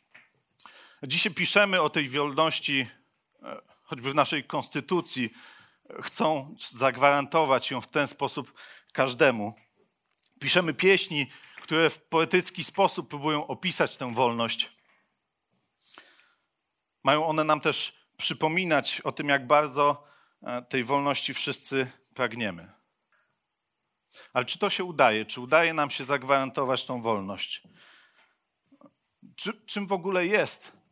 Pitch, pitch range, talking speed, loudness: 145 Hz, 135-165 Hz, 110 wpm, -26 LUFS